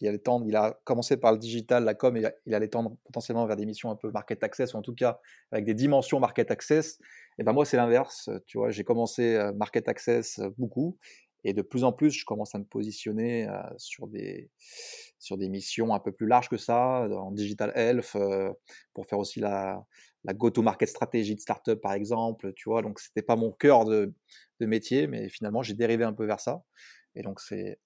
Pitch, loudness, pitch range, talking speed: 115 Hz, -28 LUFS, 105-120 Hz, 215 wpm